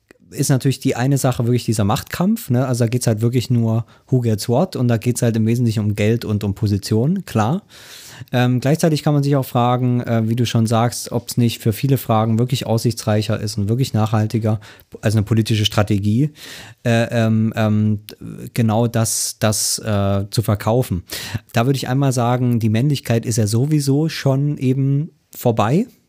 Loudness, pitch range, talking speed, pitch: -18 LUFS, 110-130 Hz, 190 wpm, 120 Hz